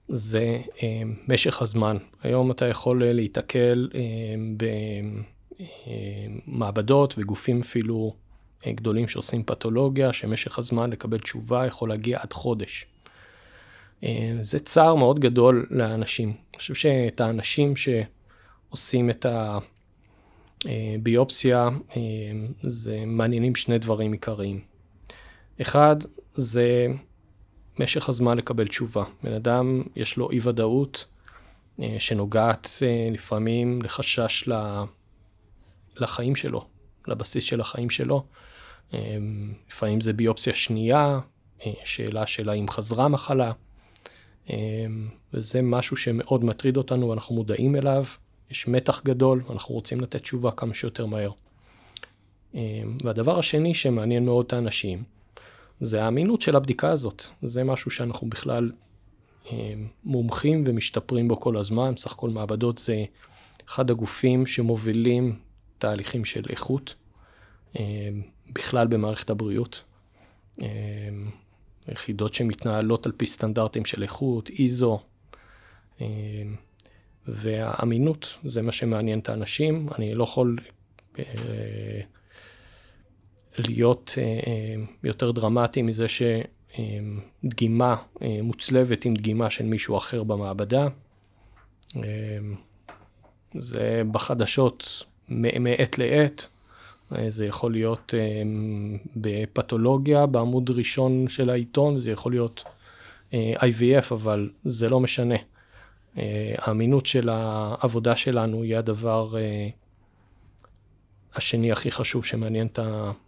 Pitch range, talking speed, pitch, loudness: 105-125 Hz, 110 wpm, 115 Hz, -25 LUFS